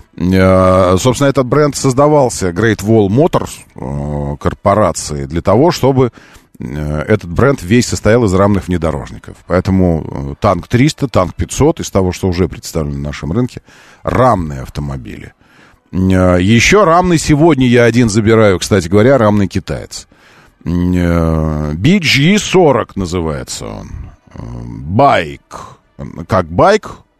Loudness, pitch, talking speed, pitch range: -12 LUFS, 95 Hz, 125 wpm, 85-125 Hz